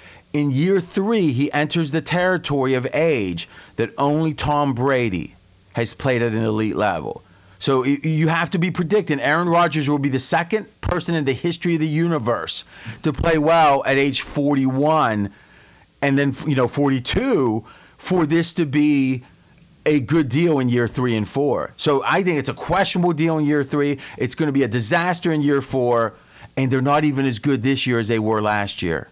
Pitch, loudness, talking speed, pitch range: 140 Hz, -20 LUFS, 190 wpm, 125-160 Hz